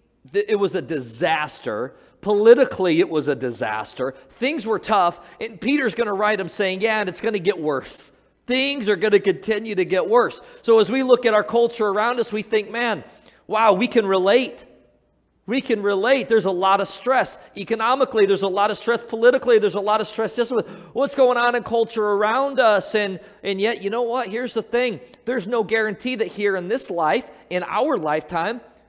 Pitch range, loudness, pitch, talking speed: 195-235 Hz, -20 LUFS, 215 Hz, 205 wpm